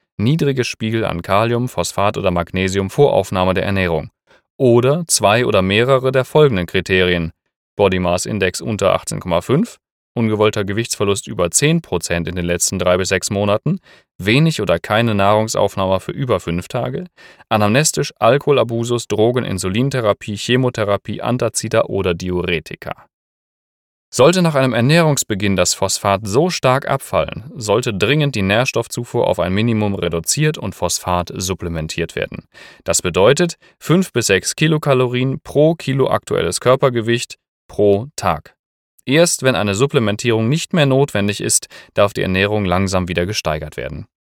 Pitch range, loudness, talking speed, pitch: 95-135 Hz, -16 LUFS, 135 wpm, 105 Hz